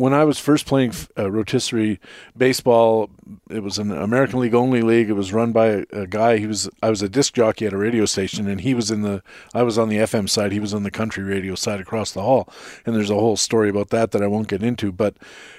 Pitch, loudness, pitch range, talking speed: 110 Hz, -20 LUFS, 100-115 Hz, 255 wpm